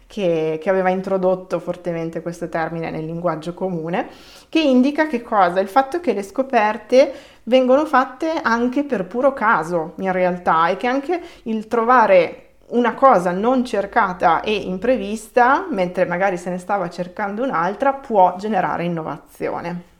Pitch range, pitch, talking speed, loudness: 180-255 Hz, 205 Hz, 145 wpm, -19 LUFS